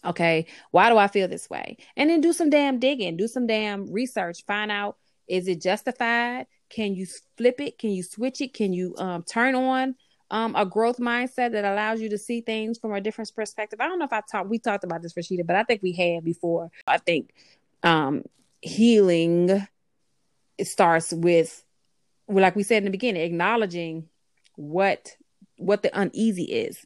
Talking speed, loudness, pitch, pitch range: 190 wpm, -24 LUFS, 210 Hz, 185-235 Hz